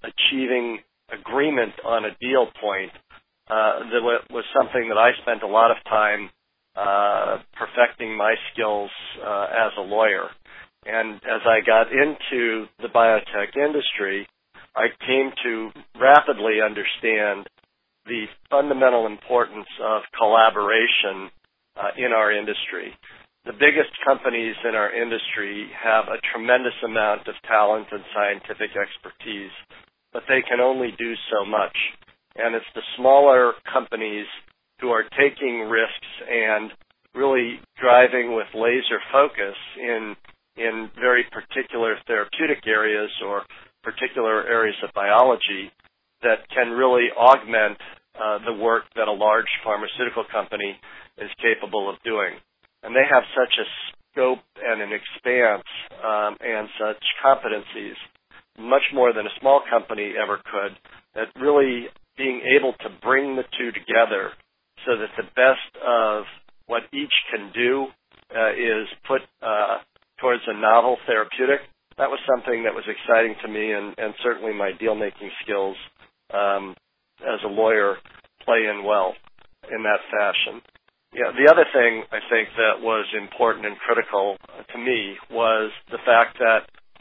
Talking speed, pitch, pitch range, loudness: 140 wpm, 115 Hz, 105-125 Hz, -21 LUFS